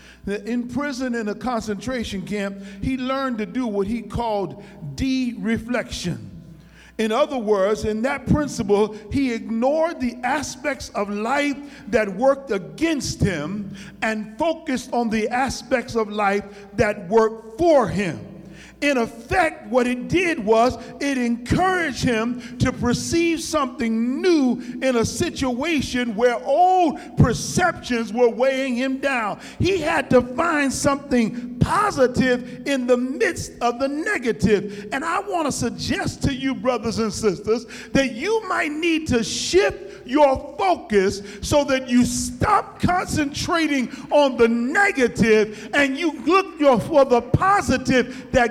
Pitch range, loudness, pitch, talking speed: 225-280 Hz, -21 LUFS, 245 Hz, 135 wpm